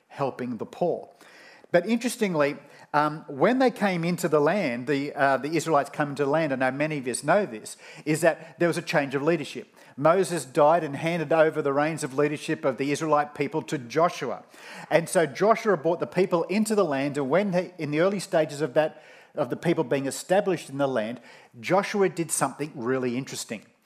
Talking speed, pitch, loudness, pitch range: 200 wpm, 155 Hz, -25 LUFS, 145-175 Hz